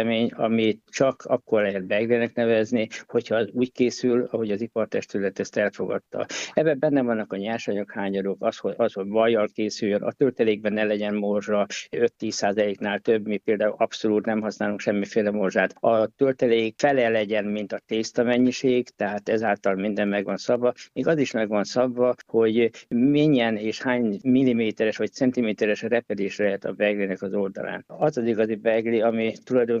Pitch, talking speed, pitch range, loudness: 110 Hz, 165 wpm, 105-120 Hz, -24 LUFS